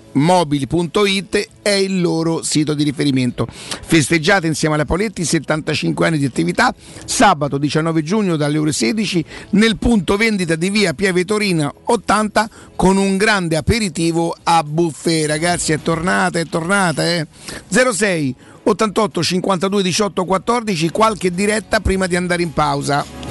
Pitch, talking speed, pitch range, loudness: 175 Hz, 135 wpm, 155-200 Hz, -16 LUFS